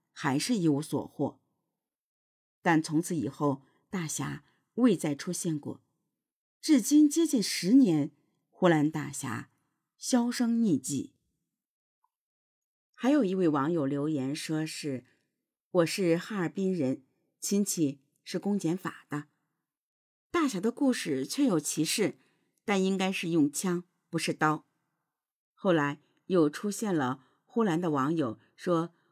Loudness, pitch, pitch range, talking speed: -29 LUFS, 165 Hz, 150-200 Hz, 175 characters per minute